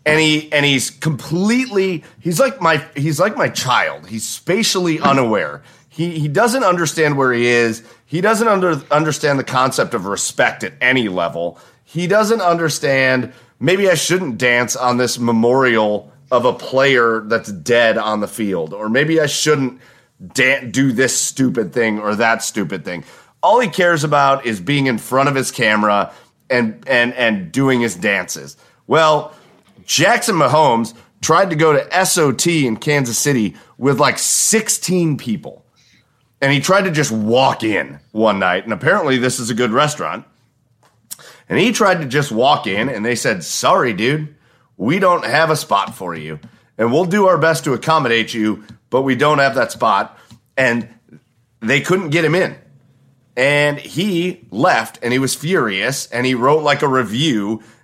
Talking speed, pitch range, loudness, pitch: 170 wpm, 120-160 Hz, -16 LUFS, 135 Hz